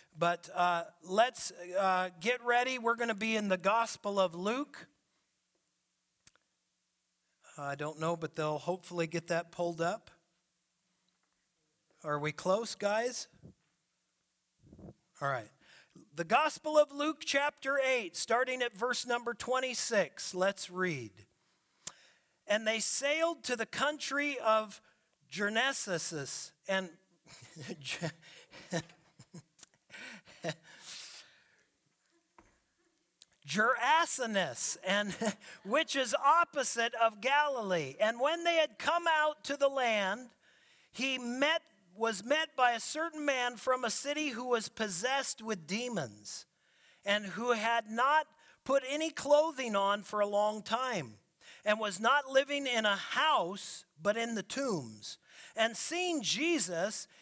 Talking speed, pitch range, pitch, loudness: 115 wpm, 180-270 Hz, 220 Hz, -32 LUFS